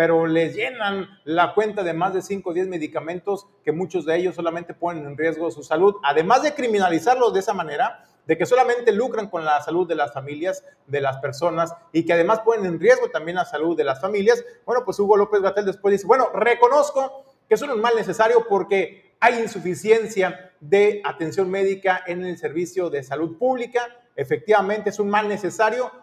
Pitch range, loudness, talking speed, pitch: 170-220 Hz, -21 LUFS, 200 wpm, 190 Hz